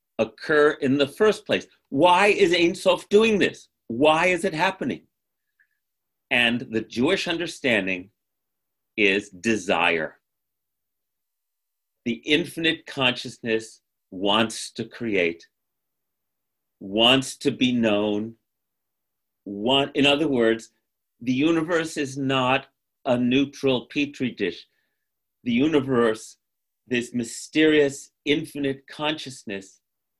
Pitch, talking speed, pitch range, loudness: 135 Hz, 95 wpm, 115-160 Hz, -22 LUFS